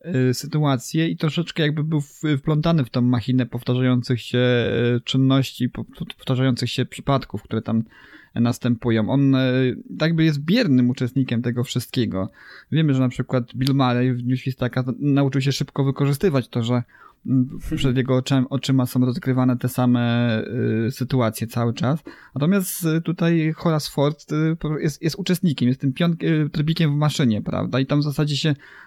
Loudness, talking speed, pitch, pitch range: -21 LUFS, 140 wpm, 130 Hz, 125-150 Hz